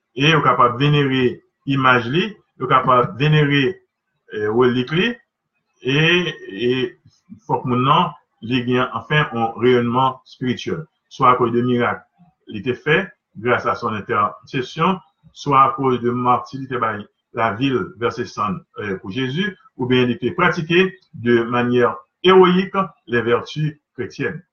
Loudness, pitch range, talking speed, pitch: -18 LUFS, 125-170 Hz, 135 wpm, 130 Hz